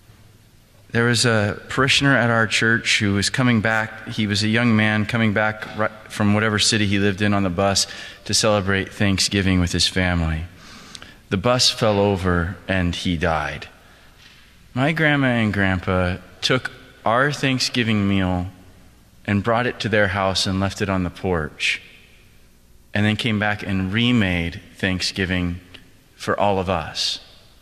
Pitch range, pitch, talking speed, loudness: 95-115 Hz, 105 Hz, 155 wpm, -20 LUFS